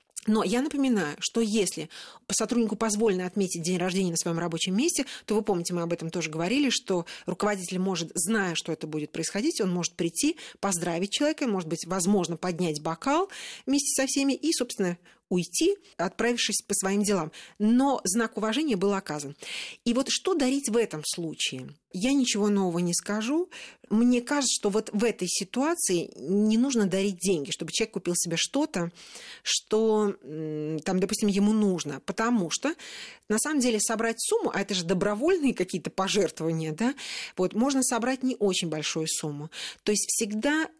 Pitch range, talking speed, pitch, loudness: 175-235 Hz, 165 wpm, 205 Hz, -27 LUFS